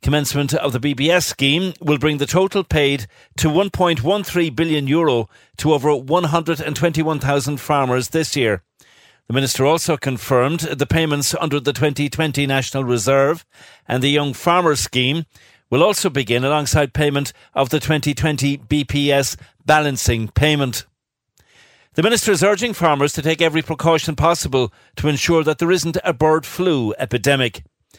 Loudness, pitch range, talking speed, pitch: -18 LUFS, 135-160 Hz, 140 wpm, 150 Hz